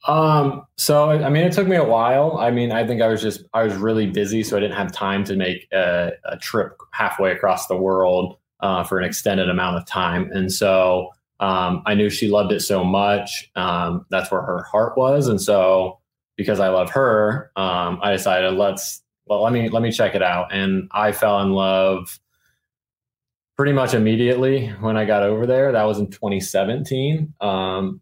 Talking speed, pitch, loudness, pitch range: 200 wpm, 105 Hz, -19 LUFS, 95-120 Hz